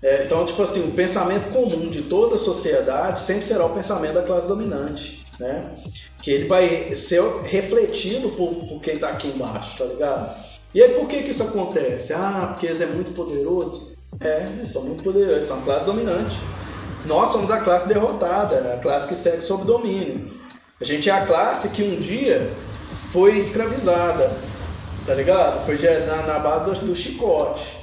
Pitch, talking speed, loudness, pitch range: 185 Hz, 185 wpm, -21 LUFS, 160-225 Hz